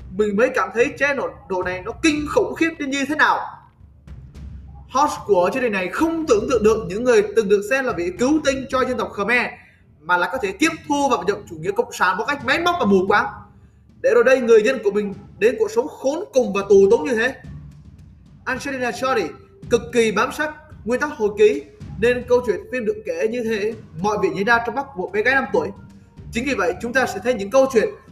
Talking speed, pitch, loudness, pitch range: 240 wpm, 255 Hz, -20 LUFS, 210-335 Hz